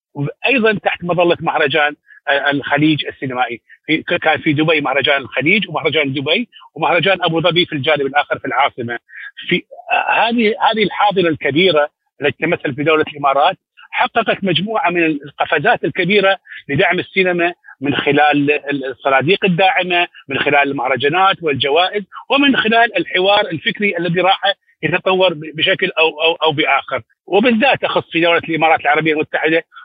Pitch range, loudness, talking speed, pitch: 145-190 Hz, -15 LUFS, 135 wpm, 165 Hz